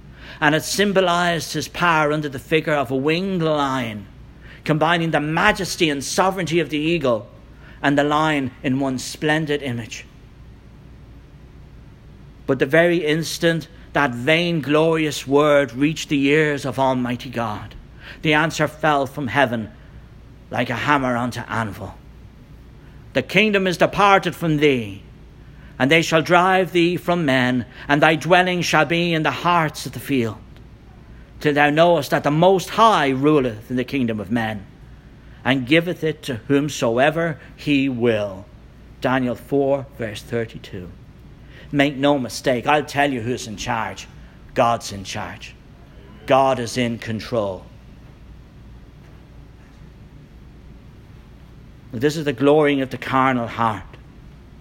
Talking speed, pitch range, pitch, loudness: 135 wpm, 125-155 Hz, 140 Hz, -19 LUFS